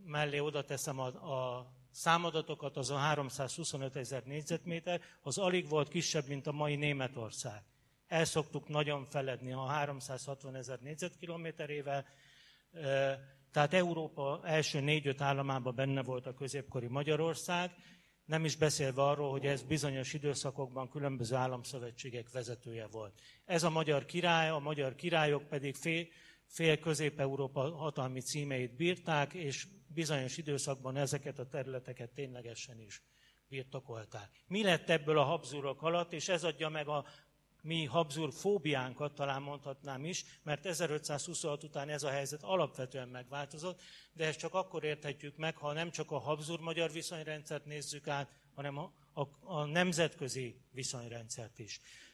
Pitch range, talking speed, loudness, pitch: 135-160 Hz, 135 wpm, -37 LUFS, 145 Hz